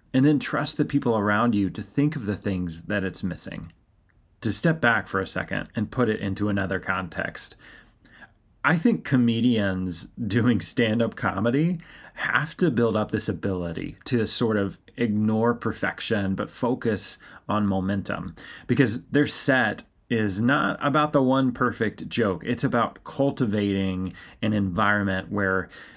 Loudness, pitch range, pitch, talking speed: -25 LUFS, 100-125 Hz, 110 Hz, 150 wpm